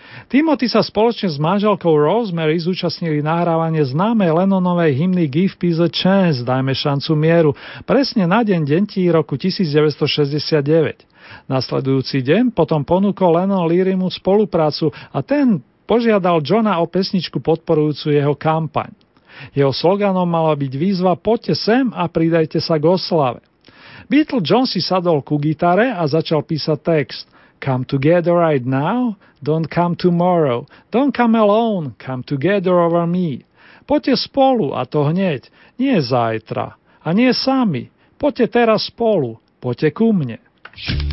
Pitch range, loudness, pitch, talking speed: 150-200 Hz, -17 LUFS, 170 Hz, 135 wpm